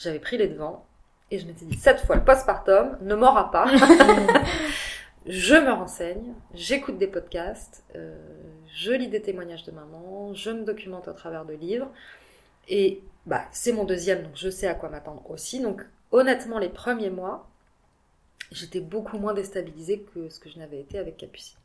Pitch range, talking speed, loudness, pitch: 165-230 Hz, 175 wpm, -23 LUFS, 190 Hz